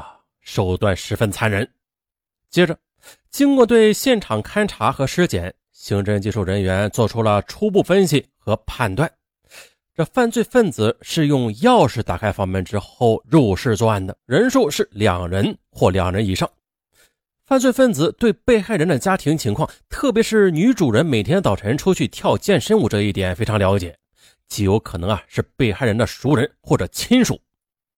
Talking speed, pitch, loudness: 250 characters per minute, 110 Hz, -18 LUFS